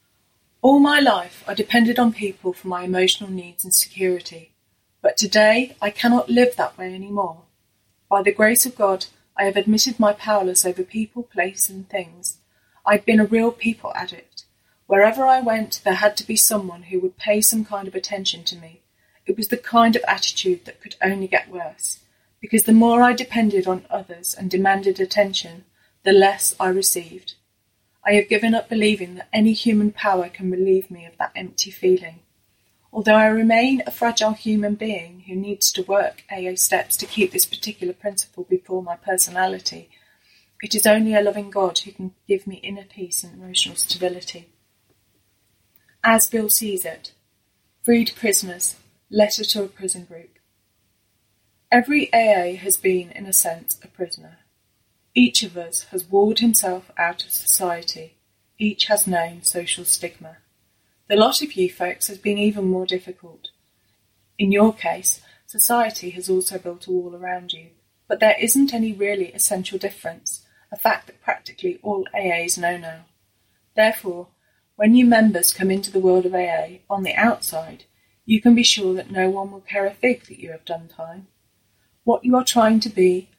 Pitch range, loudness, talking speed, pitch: 175-215 Hz, -19 LUFS, 175 wpm, 190 Hz